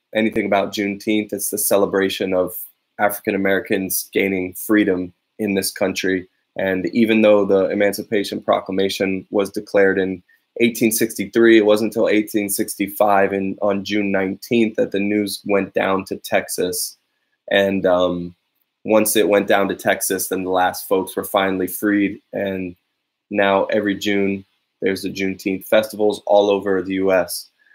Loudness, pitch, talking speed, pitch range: -19 LUFS, 100 Hz, 145 wpm, 95-105 Hz